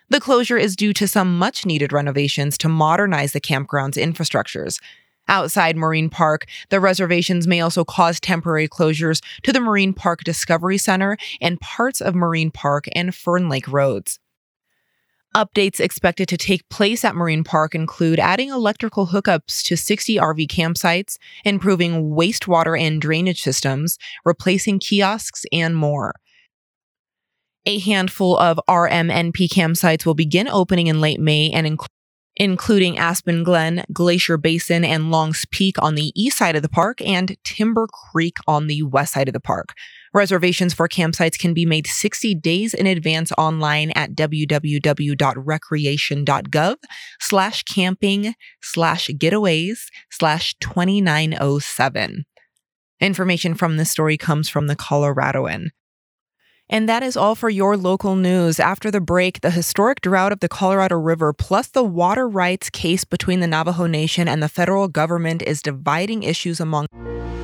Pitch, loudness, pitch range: 170 Hz, -18 LUFS, 155-195 Hz